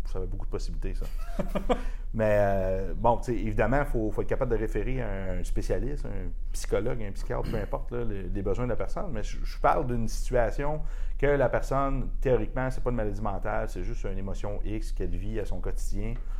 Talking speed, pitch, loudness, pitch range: 210 wpm, 110 Hz, -31 LUFS, 95-120 Hz